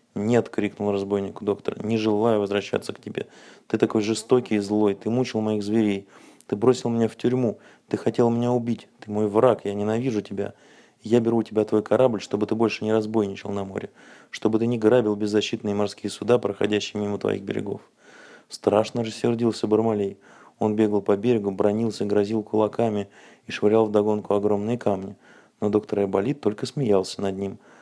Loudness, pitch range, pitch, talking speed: -24 LUFS, 100-115 Hz, 105 Hz, 175 wpm